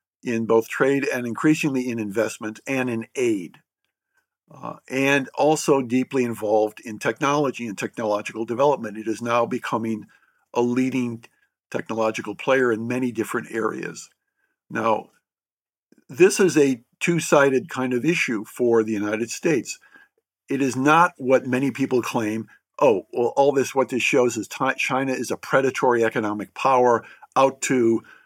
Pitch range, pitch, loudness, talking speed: 115-140 Hz, 130 Hz, -22 LUFS, 145 wpm